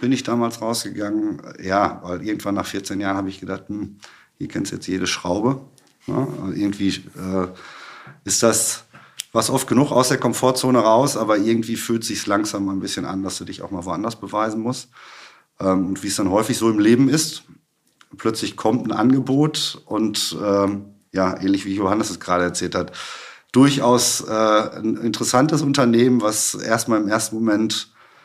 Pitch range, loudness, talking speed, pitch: 100-120 Hz, -20 LUFS, 180 wpm, 110 Hz